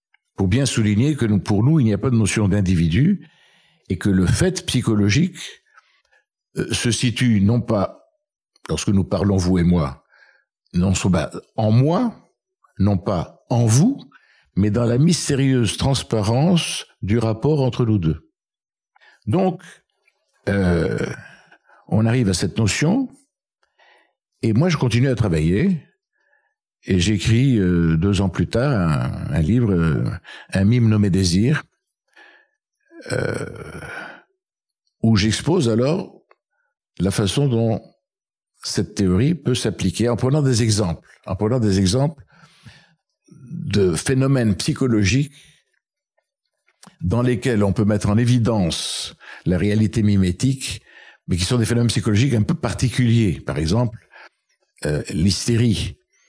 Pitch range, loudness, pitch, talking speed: 100-145 Hz, -19 LUFS, 115 Hz, 125 wpm